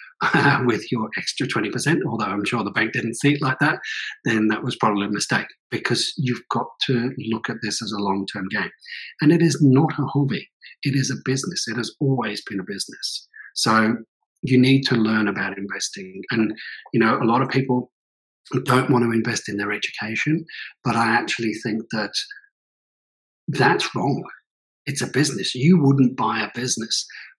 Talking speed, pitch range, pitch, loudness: 185 wpm, 110-135 Hz, 120 Hz, -22 LUFS